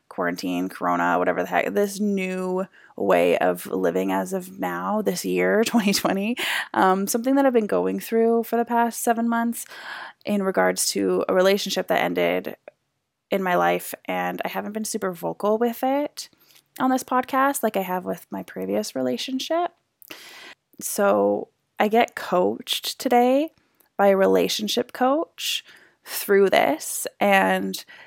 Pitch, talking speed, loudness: 200 Hz, 145 wpm, -23 LUFS